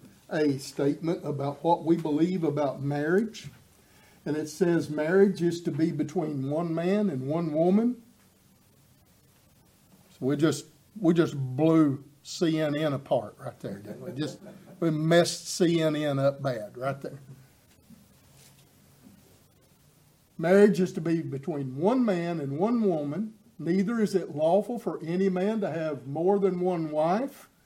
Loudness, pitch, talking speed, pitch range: -27 LUFS, 165 Hz, 140 wpm, 150-185 Hz